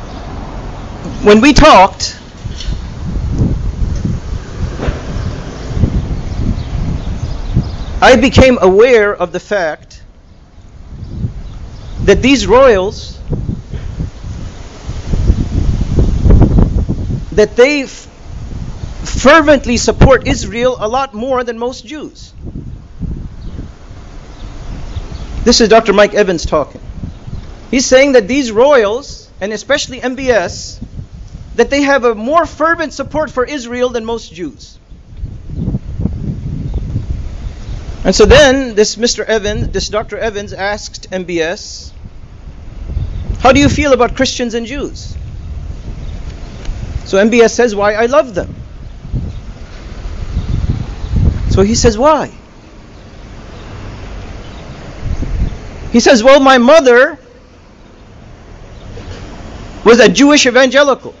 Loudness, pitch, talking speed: -11 LUFS, 210 Hz, 85 wpm